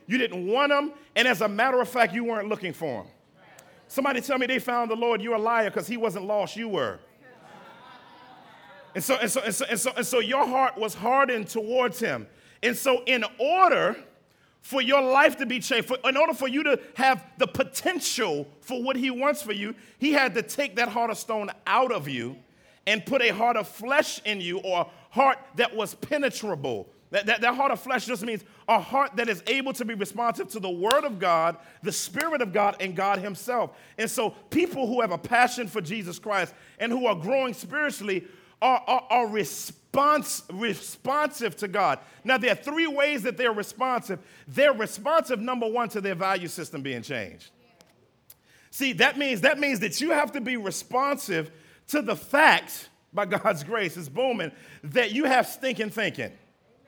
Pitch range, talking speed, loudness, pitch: 205-265 Hz, 200 wpm, -25 LUFS, 235 Hz